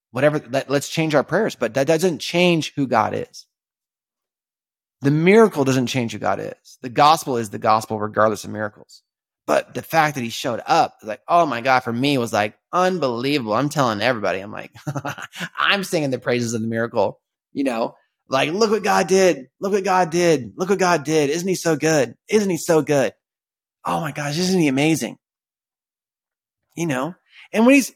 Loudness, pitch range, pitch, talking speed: -20 LUFS, 125-175 Hz, 145 Hz, 195 wpm